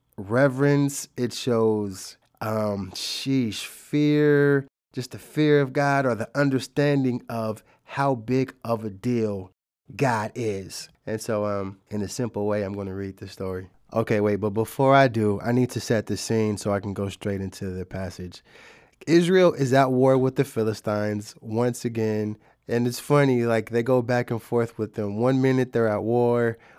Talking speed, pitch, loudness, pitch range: 175 wpm, 115 Hz, -24 LUFS, 105-130 Hz